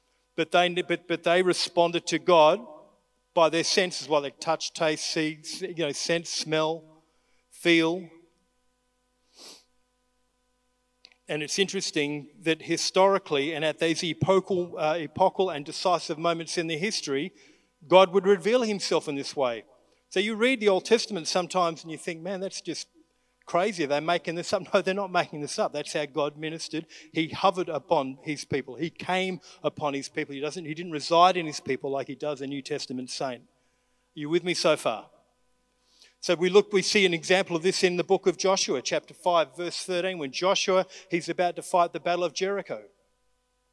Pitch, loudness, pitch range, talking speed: 175 Hz, -26 LUFS, 155-190 Hz, 185 wpm